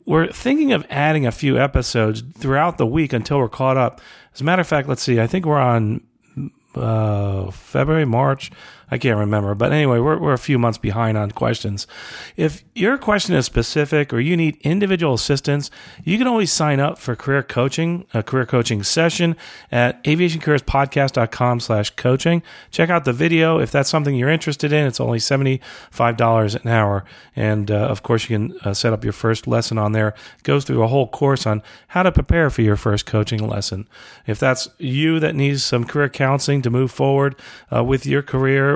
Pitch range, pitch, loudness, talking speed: 115-150 Hz, 130 Hz, -19 LUFS, 190 wpm